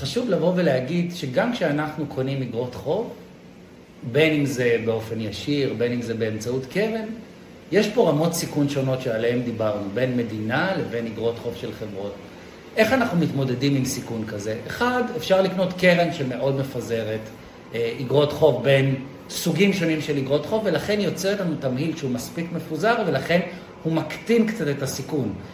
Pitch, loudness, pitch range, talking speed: 140 Hz, -23 LUFS, 120-170 Hz, 155 wpm